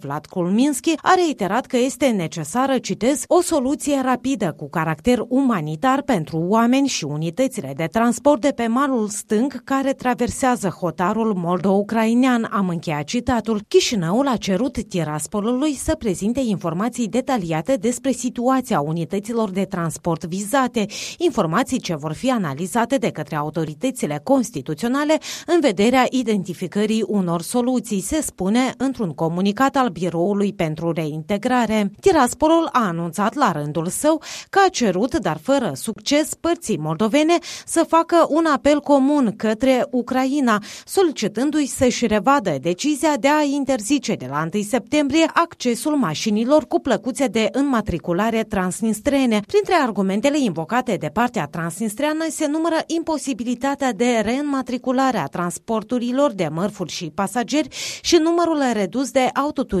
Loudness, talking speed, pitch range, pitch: -20 LUFS, 130 wpm, 195-275 Hz, 240 Hz